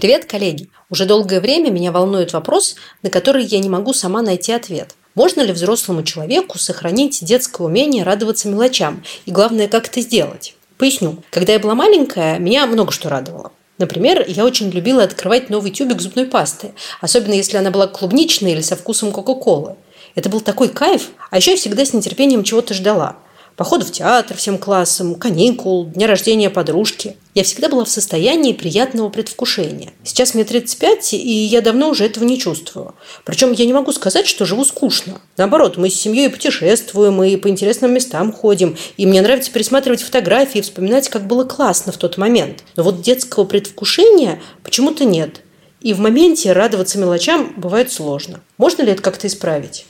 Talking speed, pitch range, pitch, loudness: 175 wpm, 185-250 Hz, 210 Hz, -14 LUFS